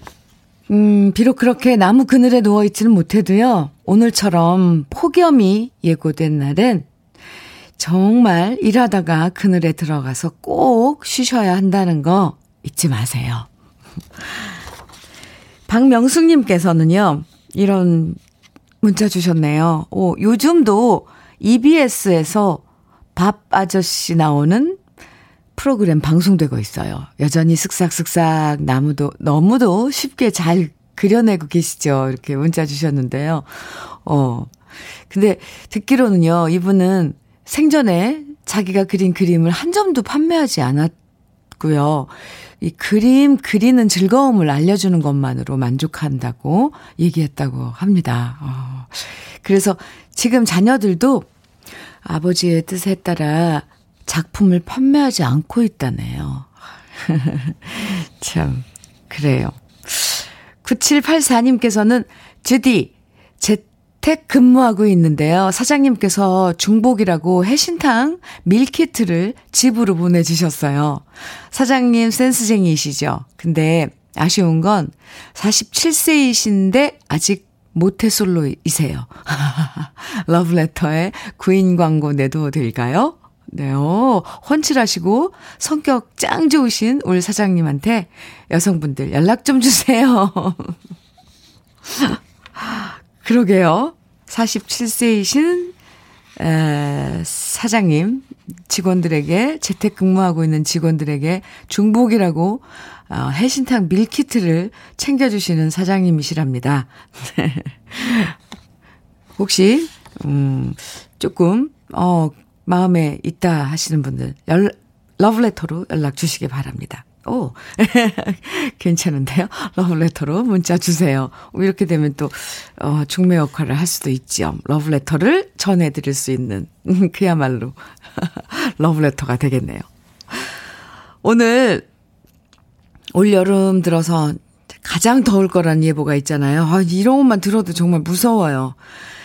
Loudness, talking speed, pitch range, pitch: -16 LUFS, 225 characters per minute, 155-225 Hz, 180 Hz